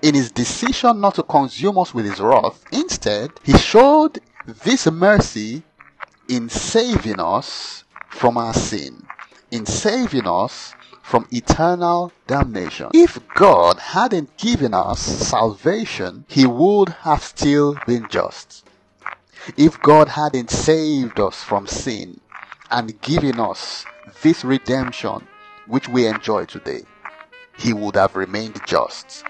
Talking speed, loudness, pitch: 125 wpm, -18 LUFS, 155 Hz